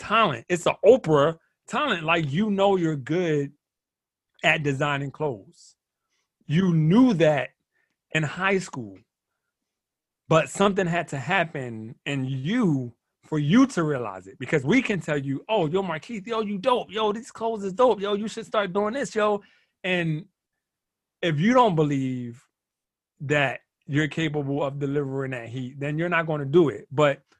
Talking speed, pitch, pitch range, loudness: 165 wpm, 160 Hz, 145-200 Hz, -24 LUFS